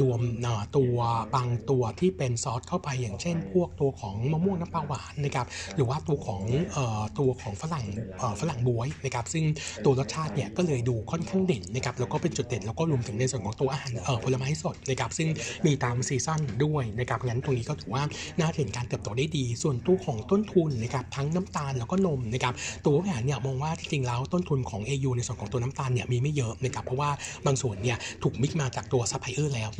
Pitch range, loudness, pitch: 120-150 Hz, -29 LUFS, 135 Hz